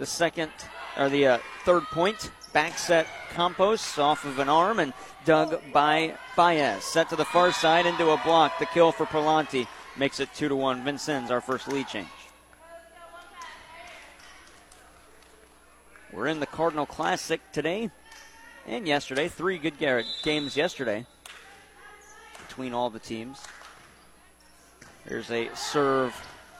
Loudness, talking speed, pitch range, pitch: -26 LUFS, 135 wpm, 140-180 Hz, 160 Hz